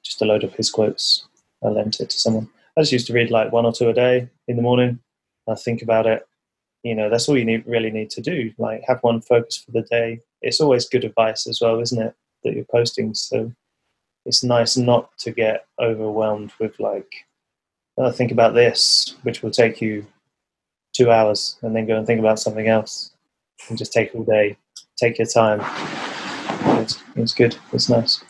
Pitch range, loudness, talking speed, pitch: 110-120 Hz, -19 LUFS, 205 wpm, 115 Hz